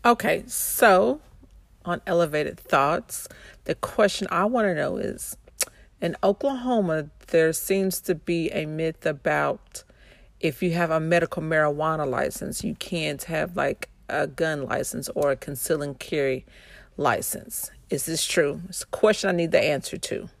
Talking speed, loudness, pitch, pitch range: 150 wpm, -25 LUFS, 165 Hz, 155-185 Hz